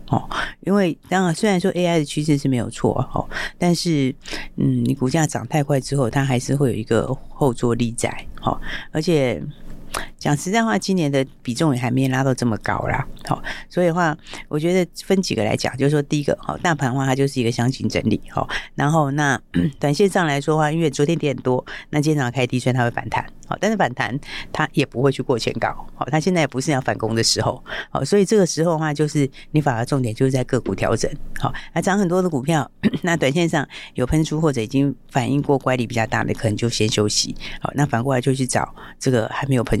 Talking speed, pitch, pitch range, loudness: 335 characters per minute, 140 Hz, 125-160 Hz, -21 LUFS